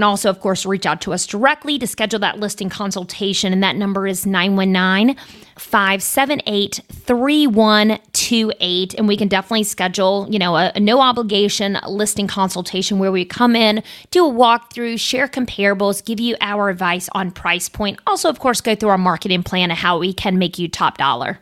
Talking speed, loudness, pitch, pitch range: 180 wpm, -17 LUFS, 200 Hz, 190-225 Hz